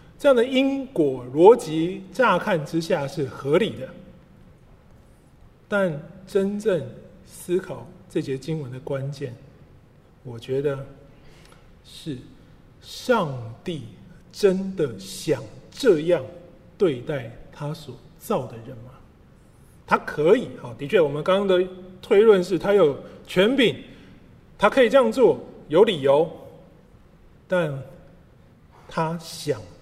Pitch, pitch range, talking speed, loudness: 165 Hz, 135-185 Hz, 155 characters per minute, -22 LUFS